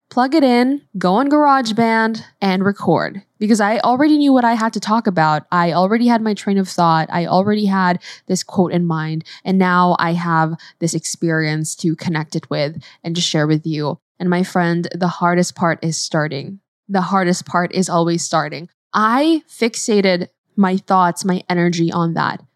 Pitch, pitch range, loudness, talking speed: 180 Hz, 170-210 Hz, -17 LUFS, 185 wpm